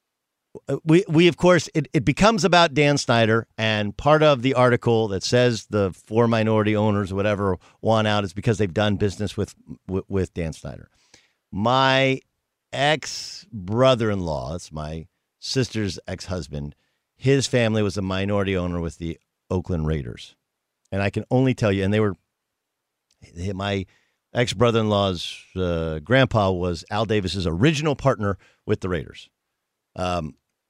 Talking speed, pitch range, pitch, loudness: 145 wpm, 95-125 Hz, 105 Hz, -22 LUFS